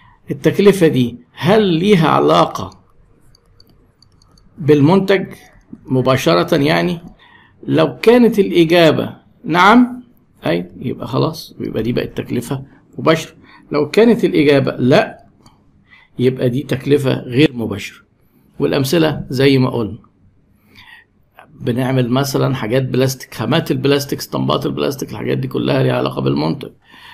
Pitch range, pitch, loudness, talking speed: 125-165 Hz, 140 Hz, -15 LUFS, 105 wpm